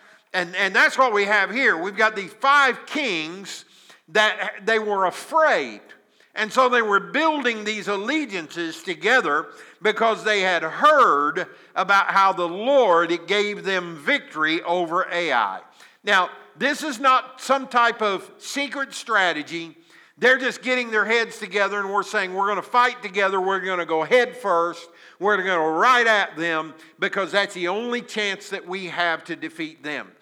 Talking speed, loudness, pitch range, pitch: 165 wpm, -21 LUFS, 180-245 Hz, 205 Hz